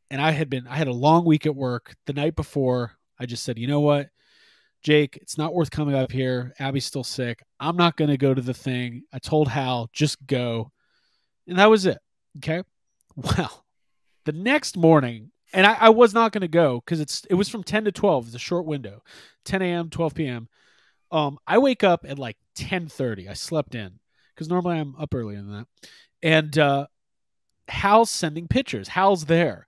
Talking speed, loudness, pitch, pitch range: 200 wpm, -22 LUFS, 150 Hz, 125-170 Hz